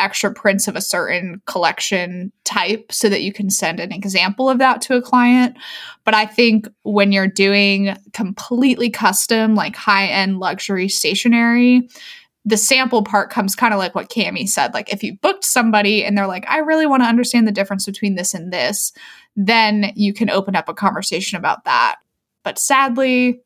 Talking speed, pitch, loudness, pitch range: 180 wpm, 210 Hz, -16 LUFS, 195-240 Hz